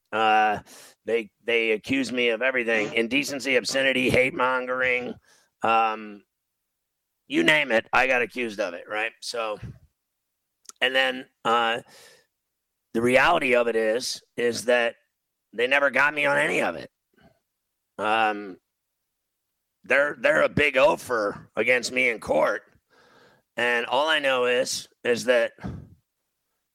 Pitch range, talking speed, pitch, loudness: 115-130 Hz, 130 wpm, 120 Hz, -23 LUFS